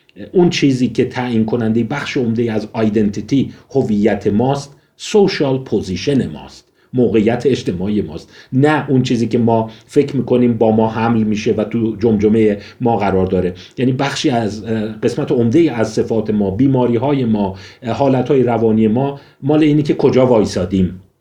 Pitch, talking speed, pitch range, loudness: 115 Hz, 155 wpm, 110-130 Hz, -15 LUFS